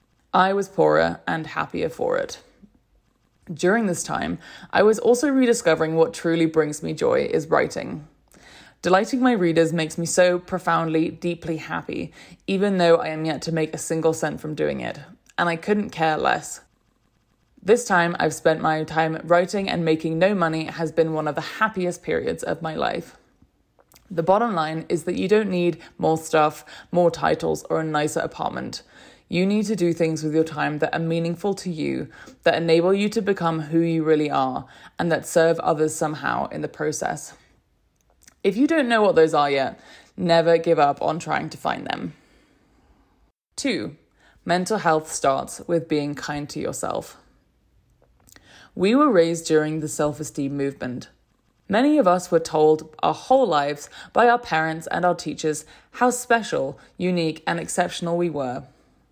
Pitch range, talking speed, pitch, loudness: 155-185 Hz, 170 wpm, 165 Hz, -22 LUFS